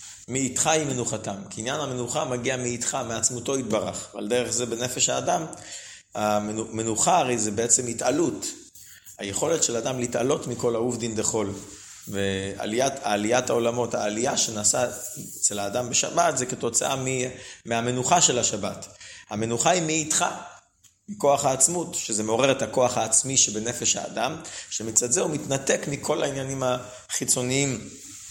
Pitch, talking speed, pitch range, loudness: 125 Hz, 130 wpm, 110-135 Hz, -24 LUFS